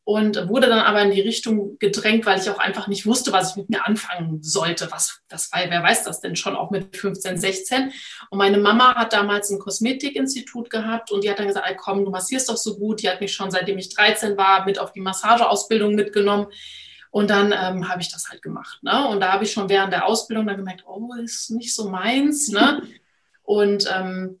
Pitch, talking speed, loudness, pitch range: 205 Hz, 225 wpm, -20 LUFS, 195-225 Hz